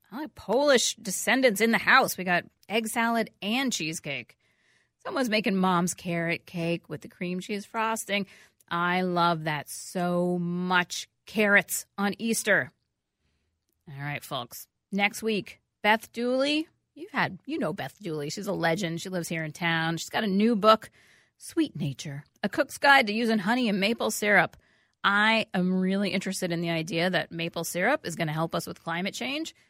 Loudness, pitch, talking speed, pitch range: -27 LUFS, 190 Hz, 170 wpm, 170-220 Hz